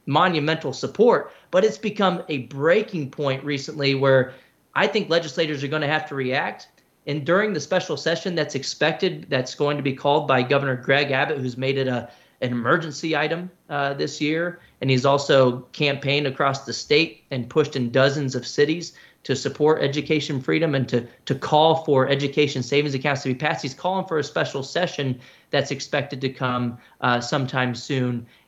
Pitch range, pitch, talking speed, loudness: 130-155 Hz, 140 Hz, 180 wpm, -22 LUFS